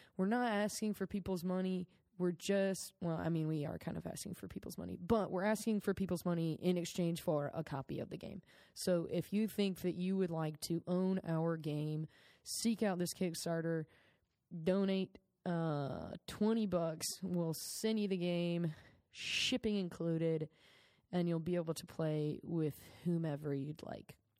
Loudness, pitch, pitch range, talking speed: -39 LUFS, 175 Hz, 160-190 Hz, 170 wpm